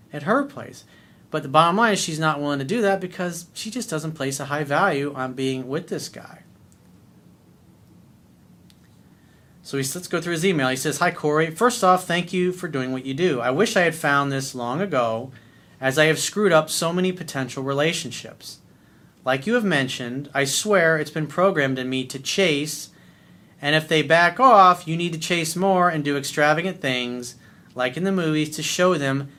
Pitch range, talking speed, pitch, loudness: 135-180 Hz, 200 wpm, 155 Hz, -21 LUFS